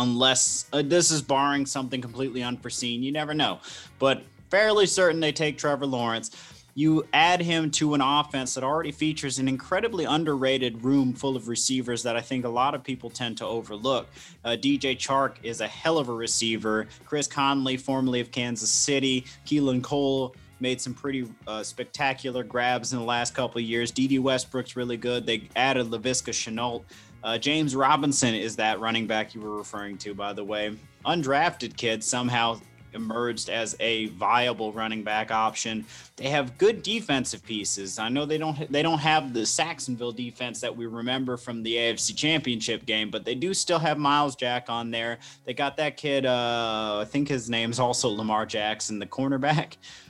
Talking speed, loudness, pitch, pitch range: 180 wpm, -26 LUFS, 125 Hz, 115-140 Hz